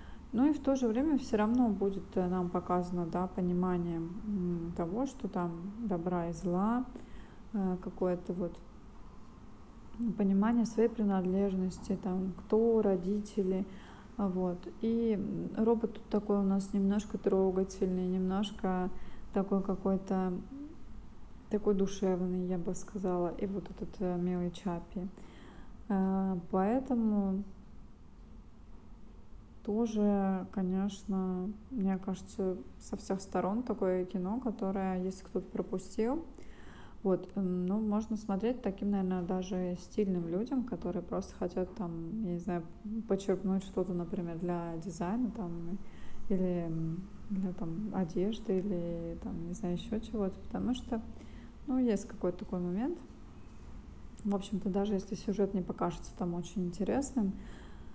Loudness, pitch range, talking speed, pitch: -34 LUFS, 185-210 Hz, 115 wpm, 195 Hz